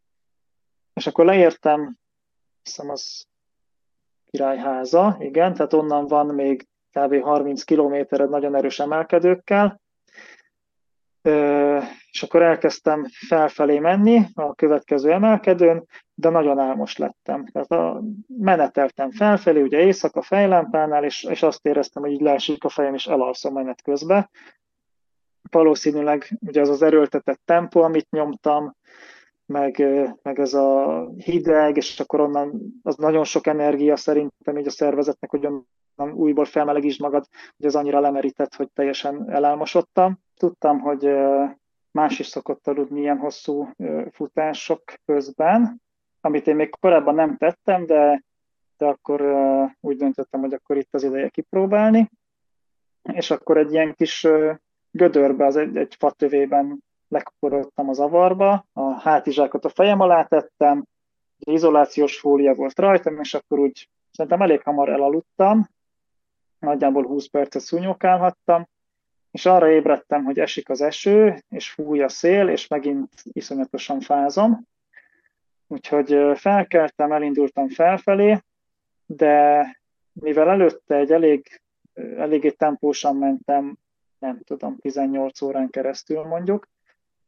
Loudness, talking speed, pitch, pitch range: -20 LUFS, 125 wpm, 150 Hz, 140-170 Hz